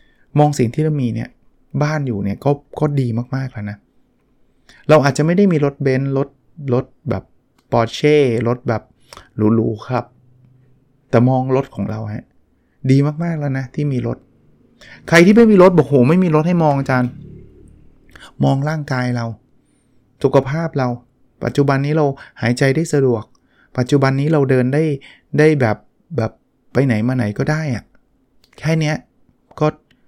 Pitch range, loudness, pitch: 120-150 Hz, -17 LUFS, 130 Hz